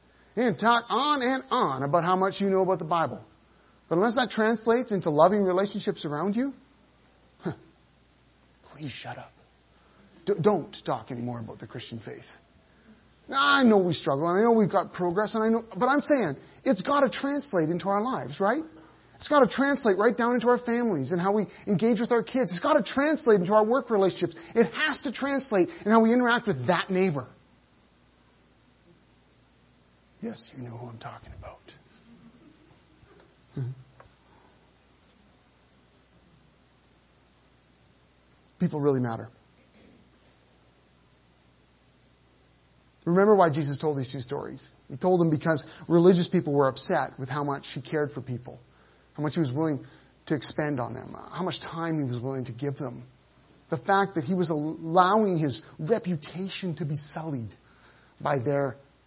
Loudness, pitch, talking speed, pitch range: -26 LUFS, 175 Hz, 160 wpm, 135-215 Hz